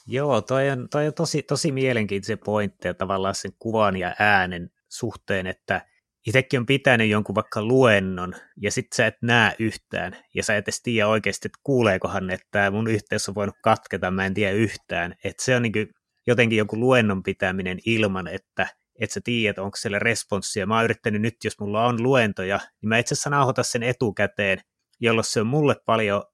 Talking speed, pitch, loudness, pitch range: 190 wpm, 110 Hz, -23 LUFS, 100-125 Hz